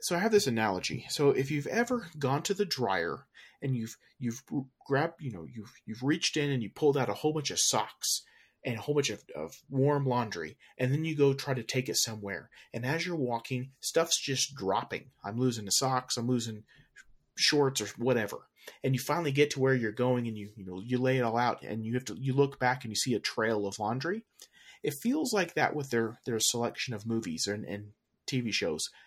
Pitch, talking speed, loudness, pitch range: 130 Hz, 225 wpm, -31 LUFS, 115-145 Hz